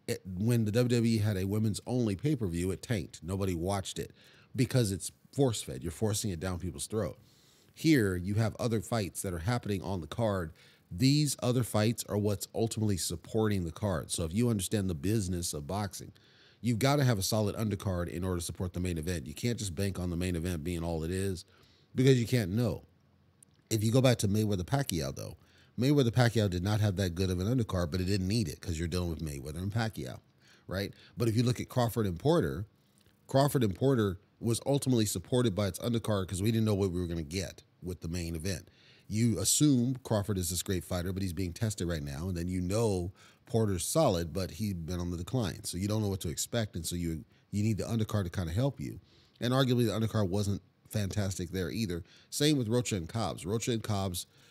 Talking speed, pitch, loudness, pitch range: 225 wpm, 105 Hz, -32 LUFS, 90-115 Hz